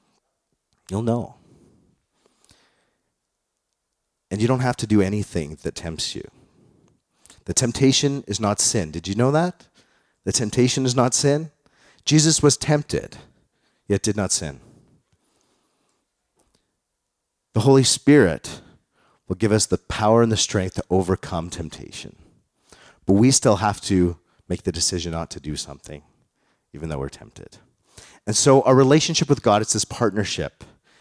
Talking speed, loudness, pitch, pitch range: 140 wpm, -20 LUFS, 105 Hz, 90-130 Hz